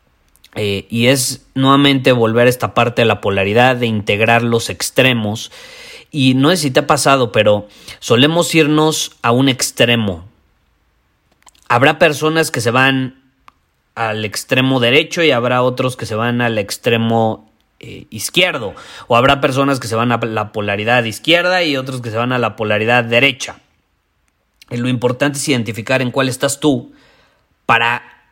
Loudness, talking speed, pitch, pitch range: -14 LUFS, 160 wpm, 125 Hz, 110-140 Hz